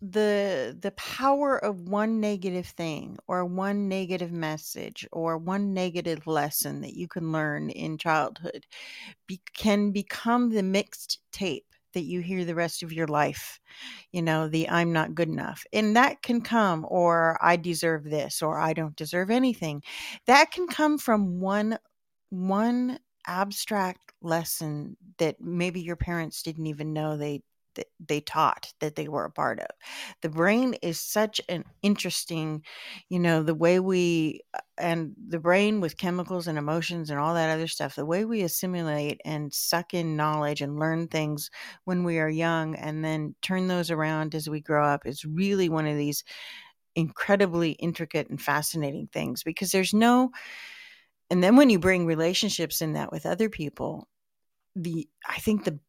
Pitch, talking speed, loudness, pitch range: 170 Hz, 165 wpm, -27 LUFS, 155-200 Hz